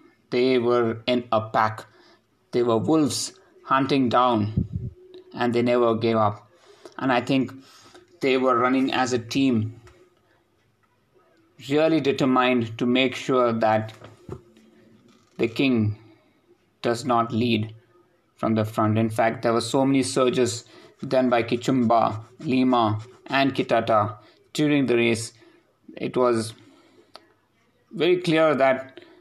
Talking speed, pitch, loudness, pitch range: 120 wpm, 125 Hz, -23 LUFS, 115-135 Hz